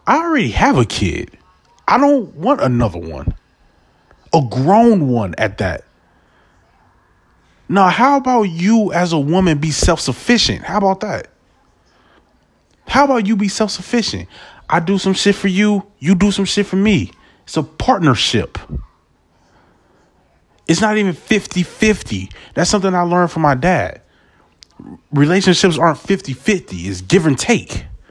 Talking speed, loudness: 145 wpm, -15 LUFS